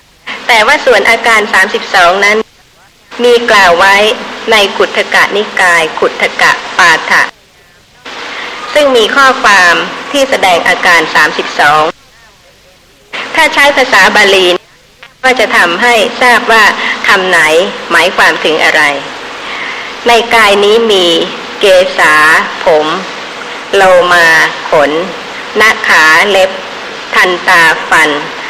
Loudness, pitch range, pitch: -6 LUFS, 195-255 Hz, 225 Hz